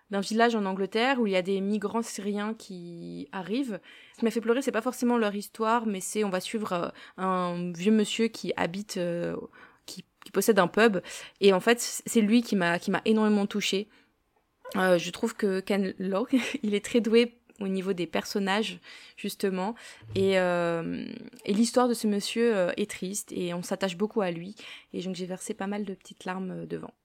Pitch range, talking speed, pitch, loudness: 185-230 Hz, 200 wpm, 205 Hz, -28 LUFS